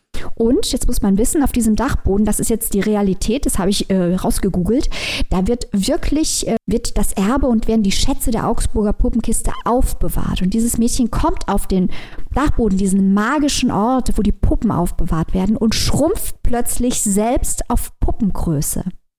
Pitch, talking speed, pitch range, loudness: 220 Hz, 170 wpm, 195-240 Hz, -18 LUFS